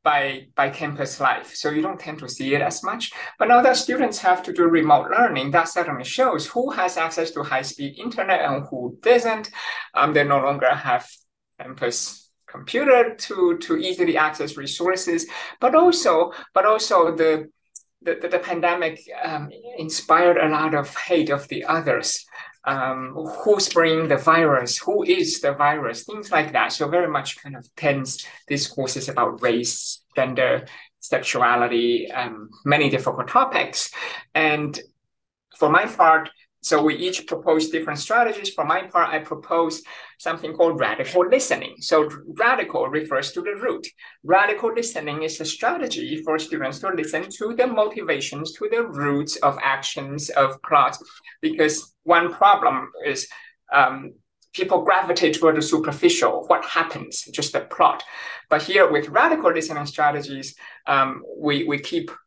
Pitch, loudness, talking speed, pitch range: 160 Hz, -21 LUFS, 155 wpm, 145-220 Hz